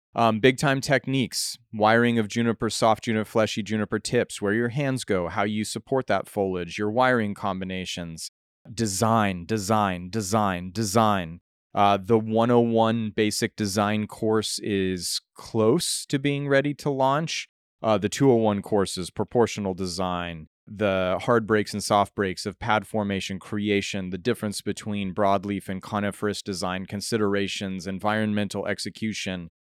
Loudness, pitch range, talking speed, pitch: -25 LUFS, 95-115 Hz, 135 wpm, 105 Hz